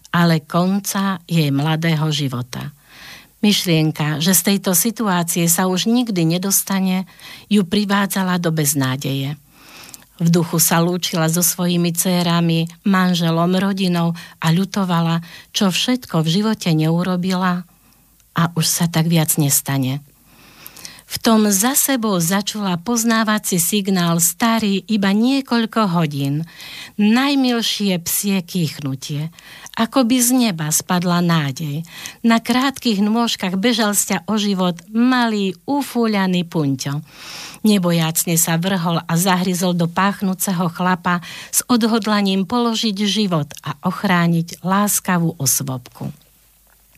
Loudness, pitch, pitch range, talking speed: -17 LUFS, 180 Hz, 165-205 Hz, 110 wpm